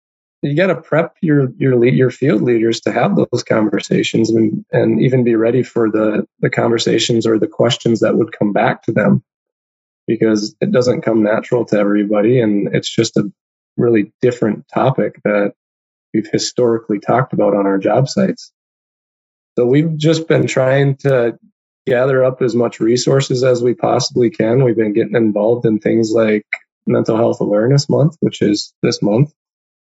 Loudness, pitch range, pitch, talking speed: -15 LUFS, 110-135 Hz, 120 Hz, 170 wpm